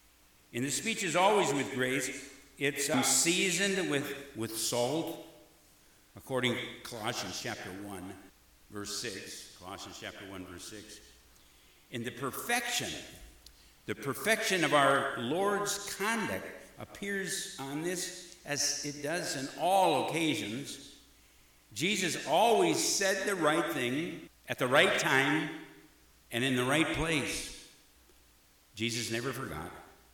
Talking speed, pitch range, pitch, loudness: 120 wpm, 100-160 Hz, 130 Hz, -31 LUFS